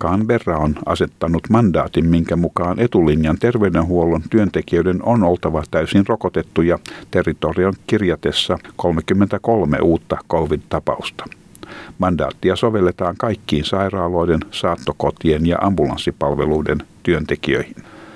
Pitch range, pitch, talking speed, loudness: 80-100 Hz, 85 Hz, 85 wpm, -18 LUFS